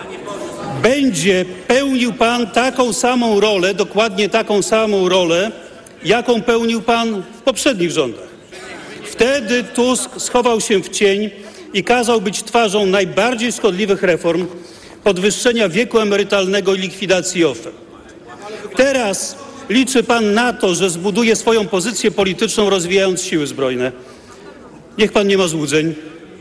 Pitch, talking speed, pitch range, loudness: 210 Hz, 120 wpm, 190-235 Hz, -15 LUFS